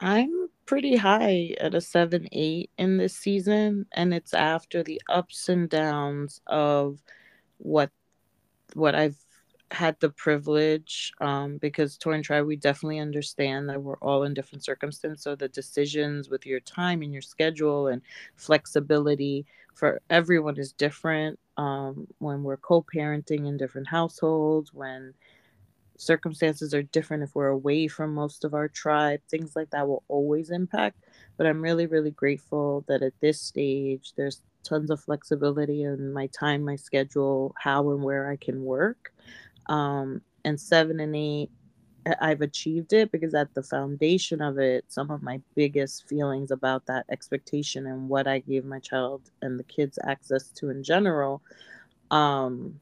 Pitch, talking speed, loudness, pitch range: 150 Hz, 160 wpm, -27 LUFS, 140-160 Hz